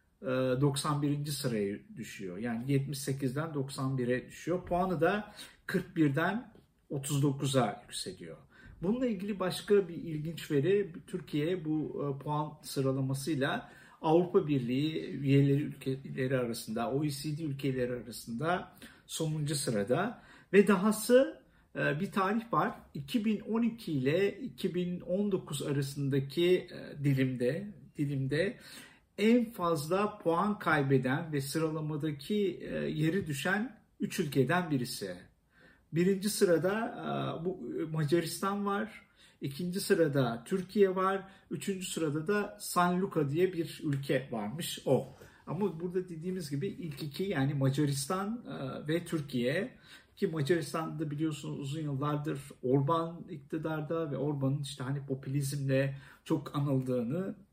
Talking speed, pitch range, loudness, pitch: 100 wpm, 140-190 Hz, -33 LUFS, 160 Hz